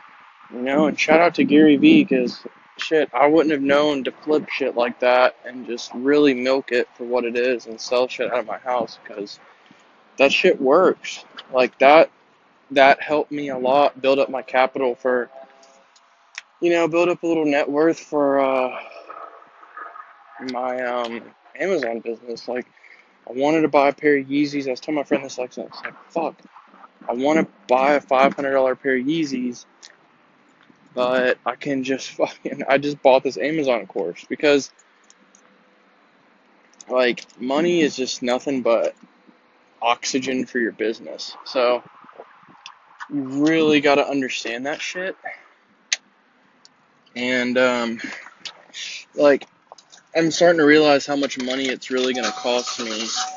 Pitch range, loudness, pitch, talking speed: 125-145 Hz, -20 LUFS, 135 Hz, 155 wpm